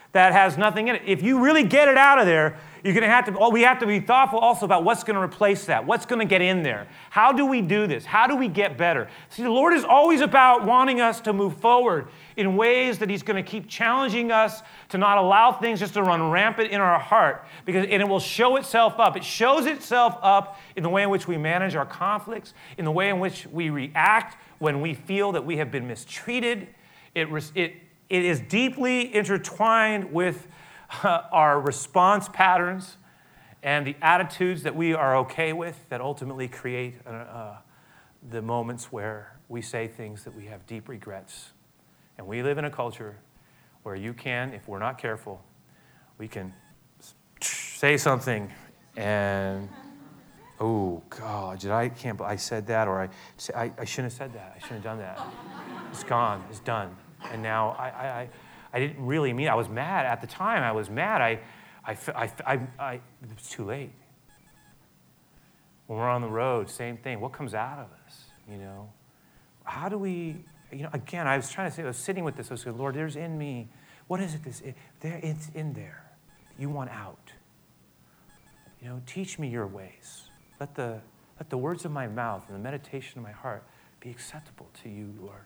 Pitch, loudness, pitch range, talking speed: 155 Hz, -23 LUFS, 120-195 Hz, 205 wpm